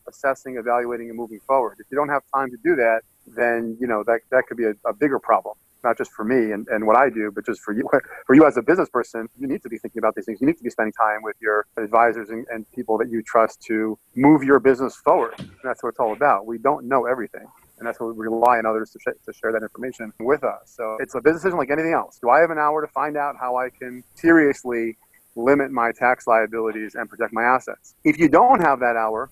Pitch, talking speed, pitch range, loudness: 120 Hz, 265 wpm, 115-135 Hz, -21 LUFS